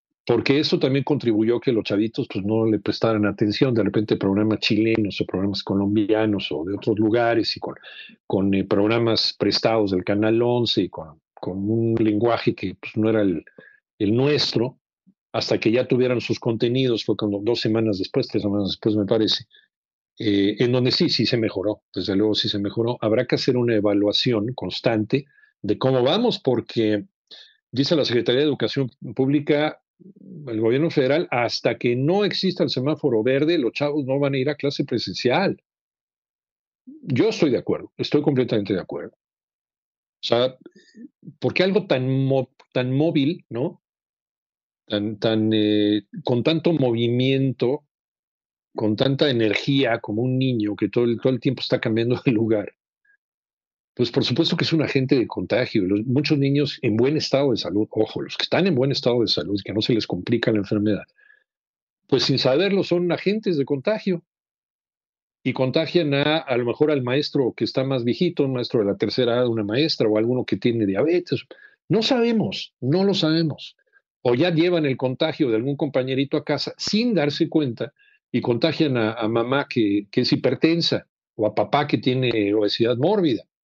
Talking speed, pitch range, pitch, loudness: 175 wpm, 110-150 Hz, 125 Hz, -22 LUFS